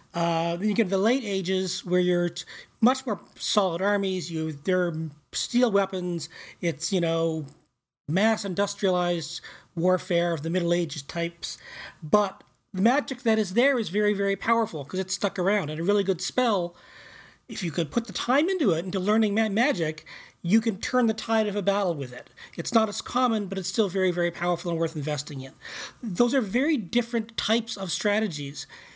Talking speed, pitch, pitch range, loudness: 185 wpm, 190 Hz, 170-220 Hz, -26 LUFS